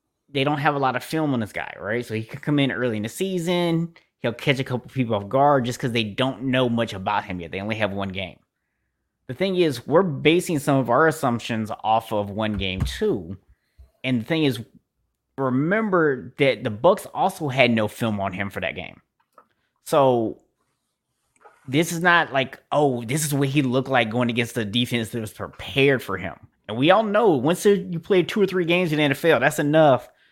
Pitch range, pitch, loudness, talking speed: 110-155 Hz, 130 Hz, -22 LUFS, 215 wpm